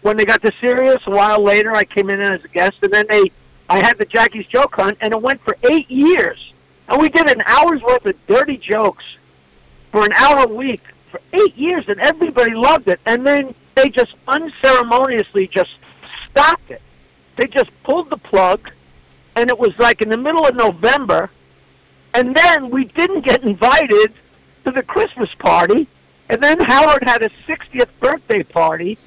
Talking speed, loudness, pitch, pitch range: 185 wpm, -14 LUFS, 245 Hz, 205-295 Hz